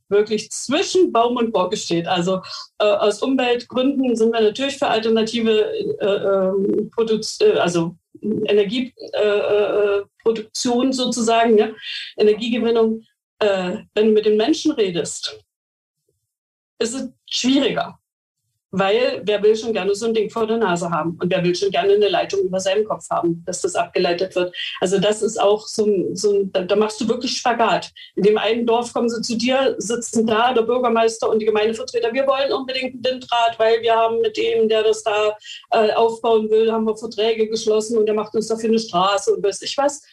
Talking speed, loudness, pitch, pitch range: 185 wpm, -19 LUFS, 225 Hz, 205-245 Hz